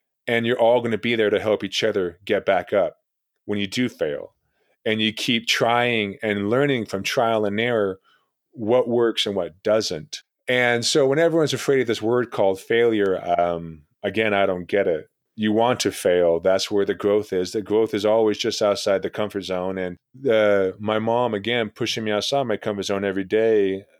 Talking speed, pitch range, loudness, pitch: 200 wpm, 100-120 Hz, -22 LUFS, 110 Hz